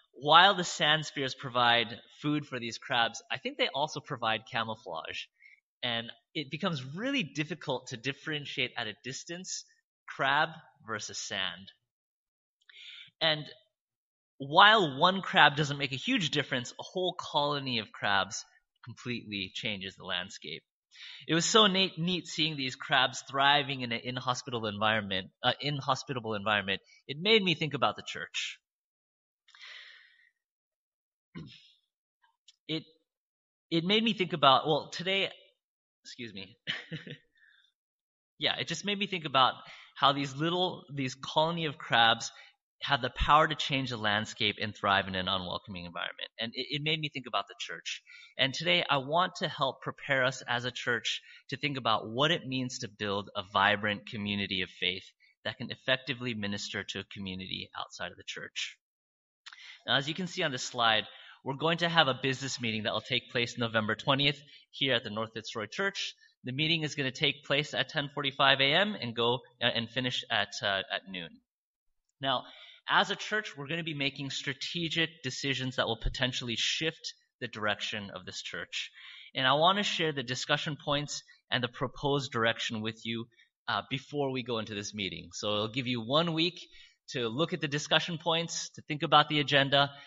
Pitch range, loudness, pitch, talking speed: 115-160 Hz, -30 LUFS, 140 Hz, 170 wpm